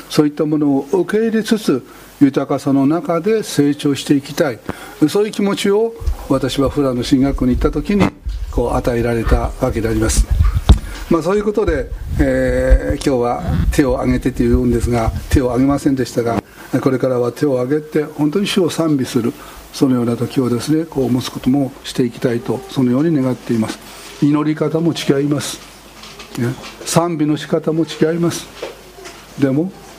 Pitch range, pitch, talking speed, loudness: 125-160 Hz, 140 Hz, 350 characters per minute, -17 LUFS